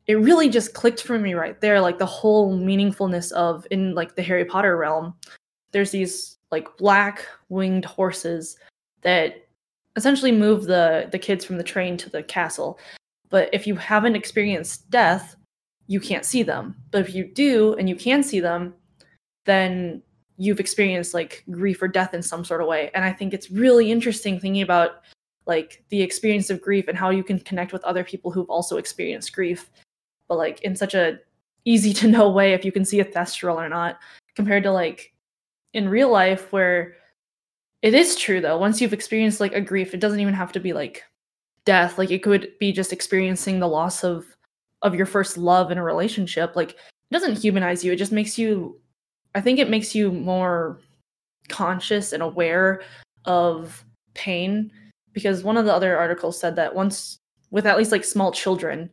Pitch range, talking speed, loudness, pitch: 175-205 Hz, 190 wpm, -21 LUFS, 190 Hz